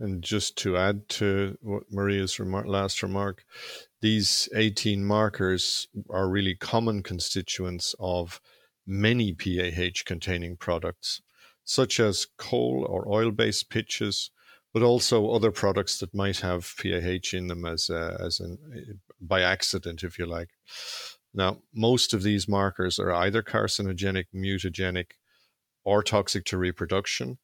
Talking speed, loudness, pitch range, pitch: 125 wpm, -27 LUFS, 90-105 Hz, 95 Hz